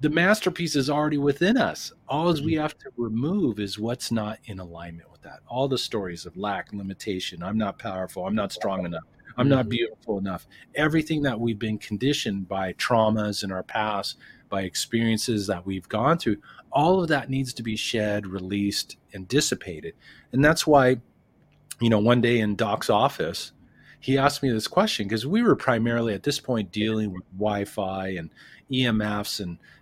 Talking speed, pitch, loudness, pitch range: 180 wpm, 115 Hz, -25 LUFS, 100-140 Hz